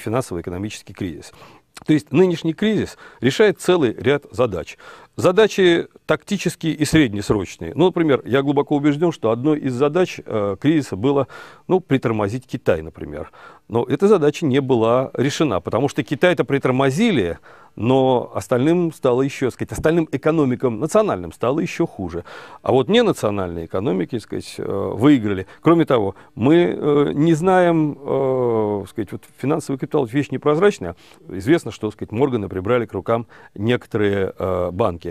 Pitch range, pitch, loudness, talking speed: 115-160 Hz, 140 Hz, -19 LUFS, 135 wpm